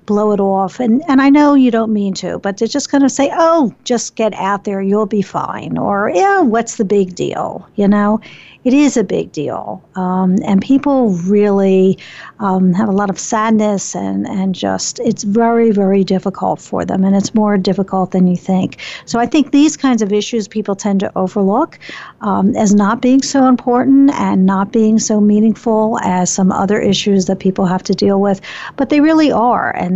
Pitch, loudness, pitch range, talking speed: 210 Hz, -13 LUFS, 195-235 Hz, 200 wpm